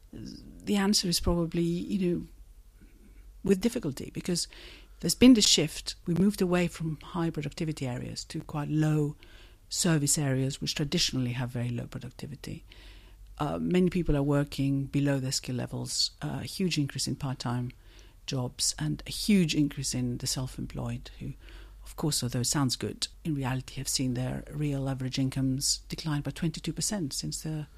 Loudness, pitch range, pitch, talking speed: -29 LUFS, 130-165 Hz, 145 Hz, 170 wpm